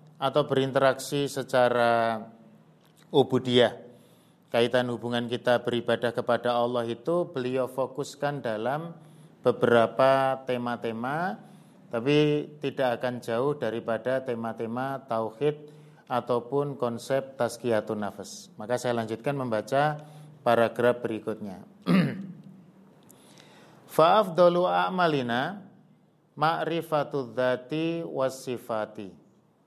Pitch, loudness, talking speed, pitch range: 130 Hz, -27 LUFS, 75 wpm, 120-150 Hz